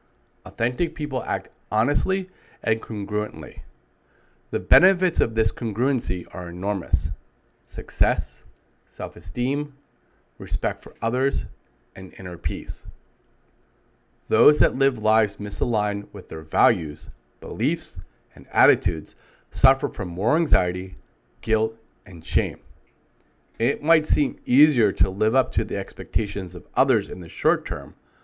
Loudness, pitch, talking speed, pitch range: -23 LUFS, 105 Hz, 120 wpm, 90-125 Hz